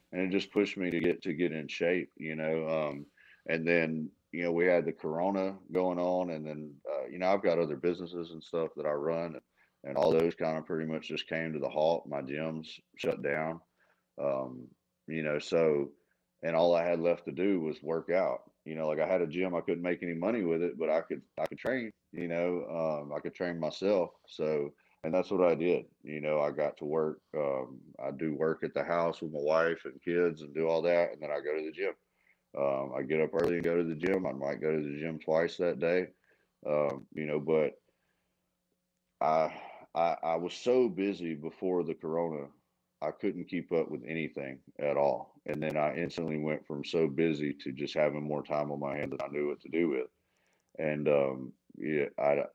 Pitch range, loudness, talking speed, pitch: 75-85 Hz, -33 LUFS, 225 wpm, 80 Hz